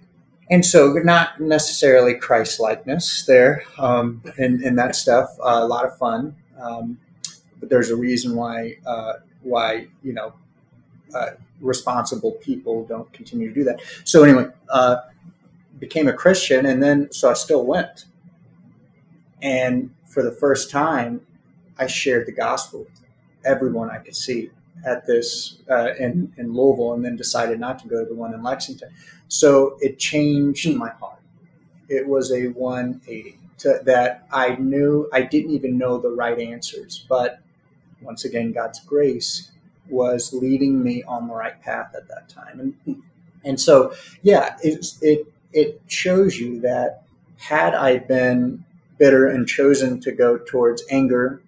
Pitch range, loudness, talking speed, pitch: 125-160 Hz, -19 LUFS, 155 wpm, 135 Hz